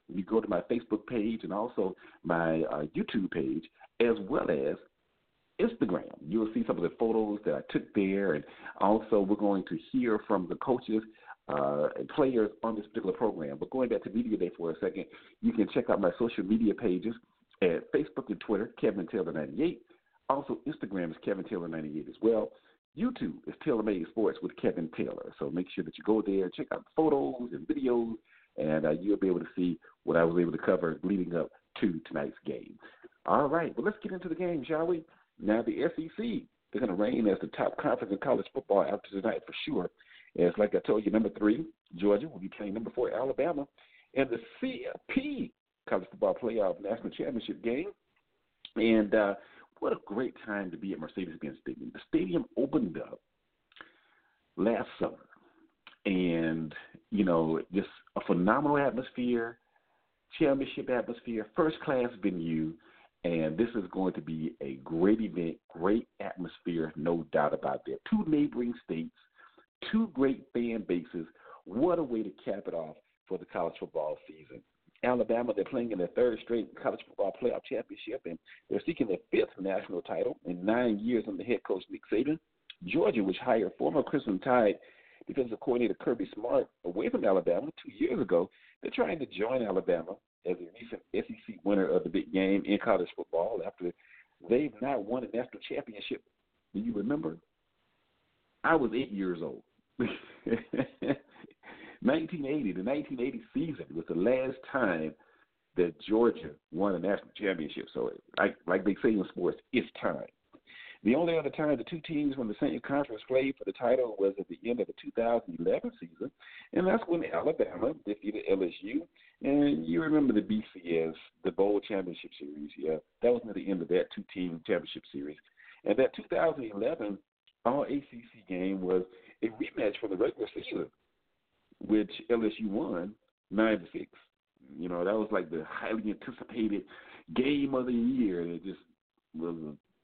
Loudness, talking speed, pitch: -32 LUFS, 175 wpm, 110 Hz